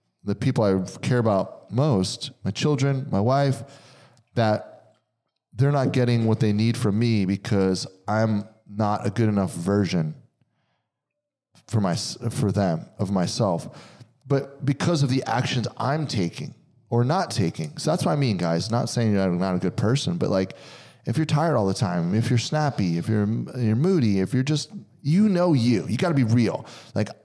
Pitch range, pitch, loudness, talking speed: 105-140 Hz, 120 Hz, -24 LUFS, 180 wpm